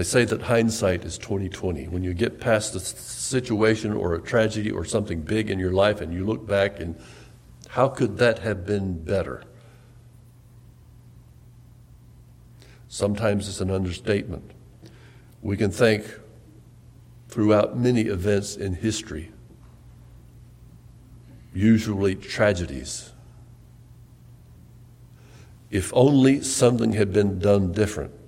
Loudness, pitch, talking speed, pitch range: -23 LUFS, 110 Hz, 110 wpm, 100-120 Hz